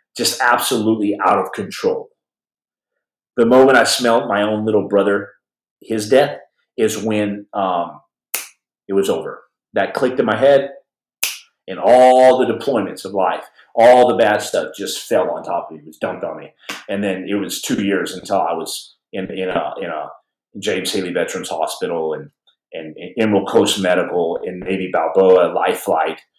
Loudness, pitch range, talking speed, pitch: -17 LUFS, 100-125 Hz, 170 wpm, 105 Hz